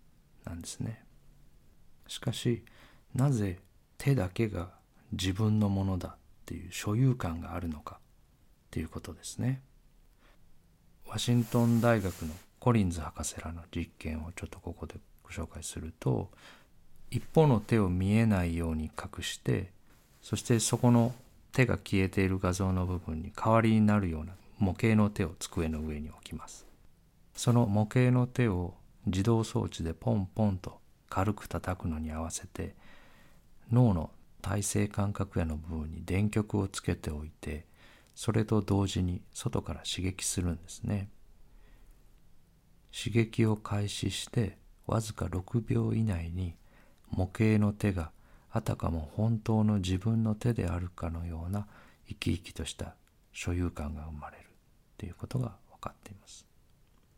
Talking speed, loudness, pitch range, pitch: 275 characters per minute, -32 LUFS, 85-110 Hz, 100 Hz